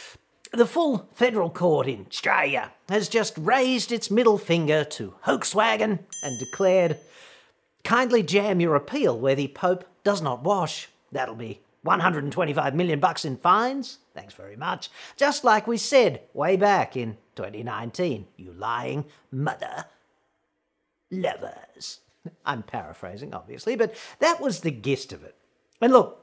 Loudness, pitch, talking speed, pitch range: -24 LUFS, 185 Hz, 140 wpm, 150-230 Hz